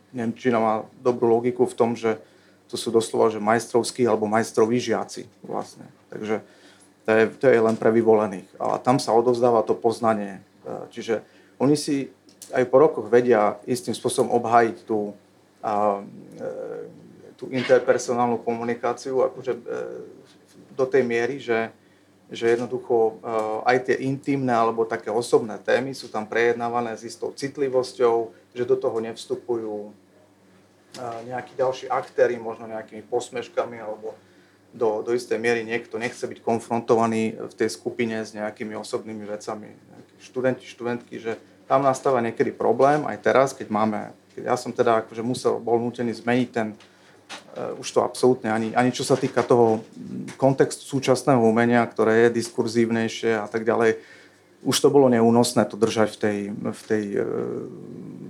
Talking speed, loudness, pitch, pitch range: 145 wpm, -23 LUFS, 115 Hz, 110-125 Hz